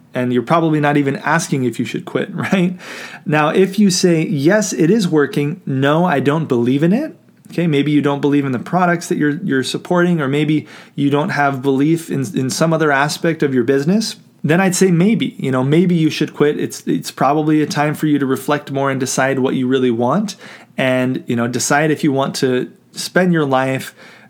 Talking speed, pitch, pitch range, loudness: 215 wpm, 150 Hz, 135-175 Hz, -16 LUFS